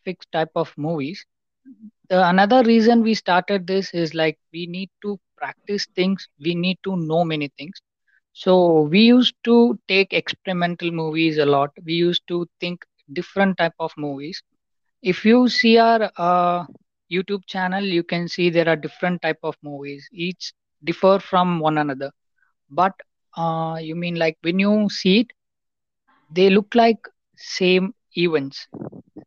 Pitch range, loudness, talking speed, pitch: 165-195 Hz, -20 LUFS, 150 wpm, 180 Hz